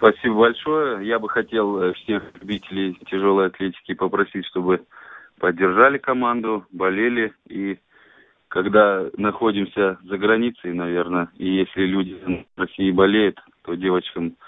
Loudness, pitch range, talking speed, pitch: -21 LUFS, 95-110 Hz, 115 wpm, 95 Hz